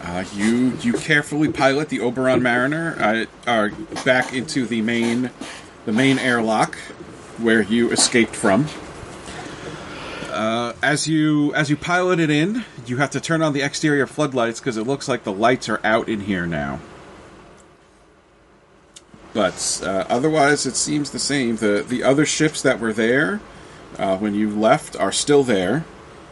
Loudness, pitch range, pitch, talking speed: -20 LUFS, 115-150 Hz, 130 Hz, 155 wpm